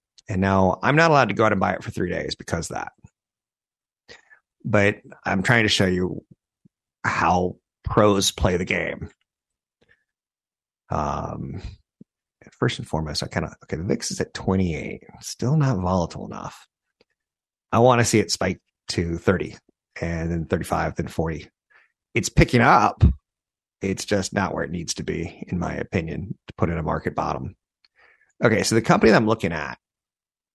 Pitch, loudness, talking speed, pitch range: 95 Hz, -22 LUFS, 170 wpm, 90-110 Hz